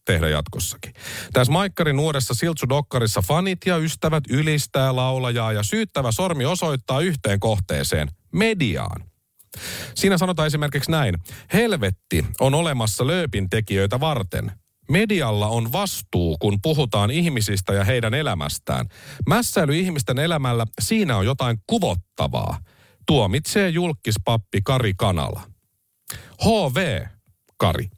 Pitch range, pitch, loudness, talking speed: 105-160 Hz, 130 Hz, -22 LUFS, 105 wpm